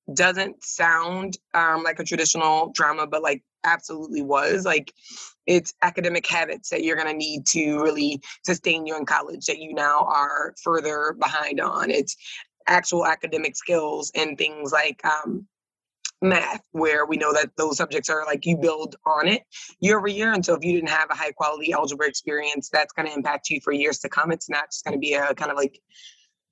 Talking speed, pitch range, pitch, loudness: 195 wpm, 150-170 Hz, 155 Hz, -23 LUFS